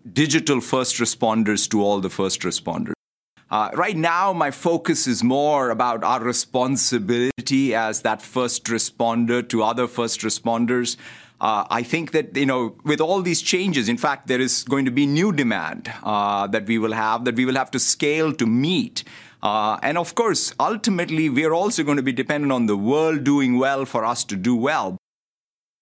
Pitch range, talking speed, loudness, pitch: 115-145 Hz, 185 wpm, -21 LUFS, 125 Hz